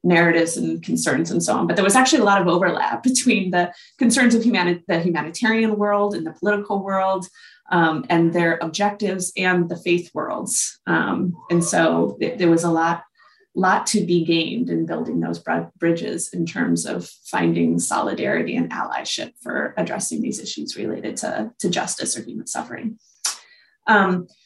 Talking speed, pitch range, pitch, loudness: 170 wpm, 165-205 Hz, 175 Hz, -20 LUFS